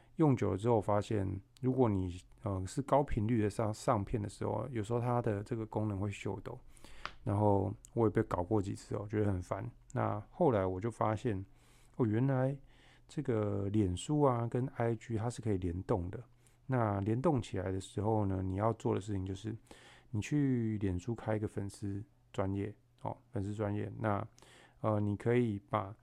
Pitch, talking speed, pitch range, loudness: 110 Hz, 260 characters per minute, 100-120 Hz, -35 LUFS